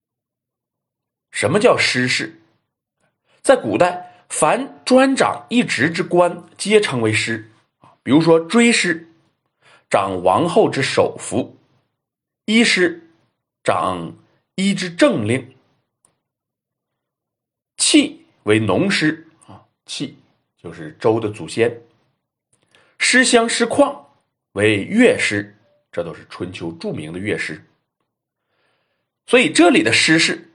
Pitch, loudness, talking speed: 175 Hz, -17 LUFS, 145 characters per minute